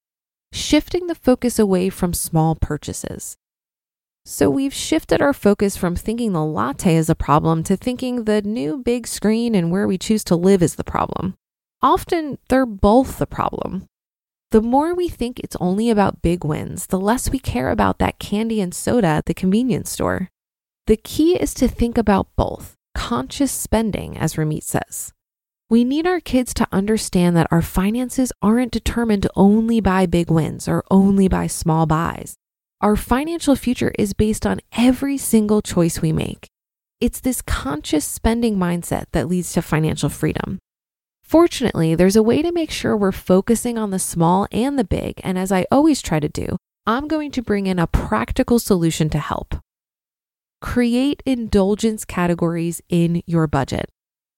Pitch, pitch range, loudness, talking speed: 205 Hz, 170-240 Hz, -19 LUFS, 170 wpm